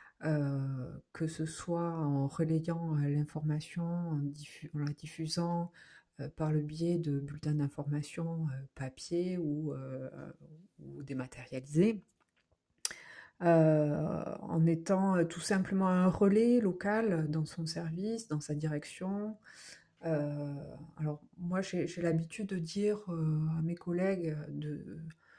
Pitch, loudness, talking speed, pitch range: 160 Hz, -34 LUFS, 130 wpm, 150-175 Hz